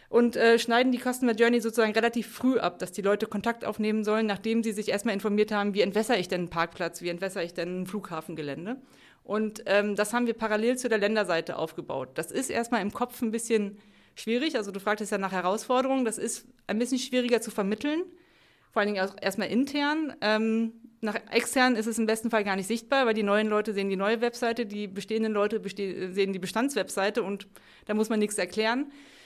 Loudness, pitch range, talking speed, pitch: -28 LUFS, 200-235 Hz, 215 wpm, 220 Hz